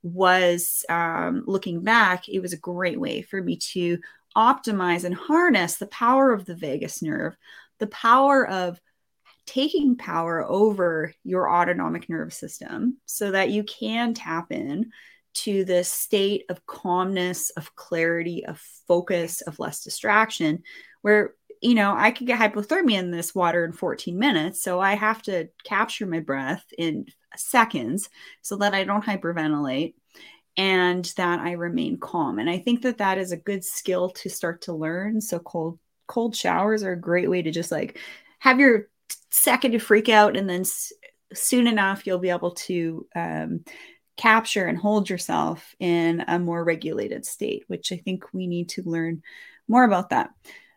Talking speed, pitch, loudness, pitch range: 165 wpm, 190 Hz, -23 LUFS, 175-220 Hz